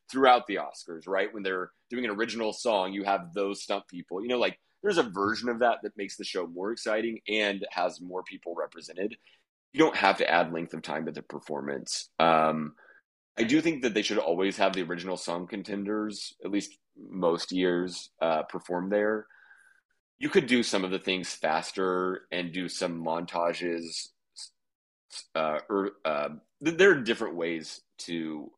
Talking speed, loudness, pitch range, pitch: 180 wpm, -29 LUFS, 85-105 Hz, 95 Hz